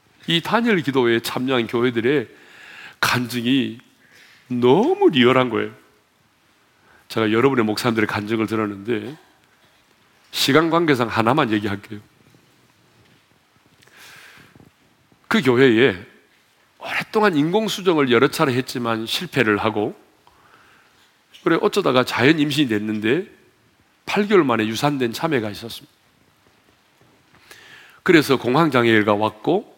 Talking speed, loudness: 240 characters per minute, -19 LUFS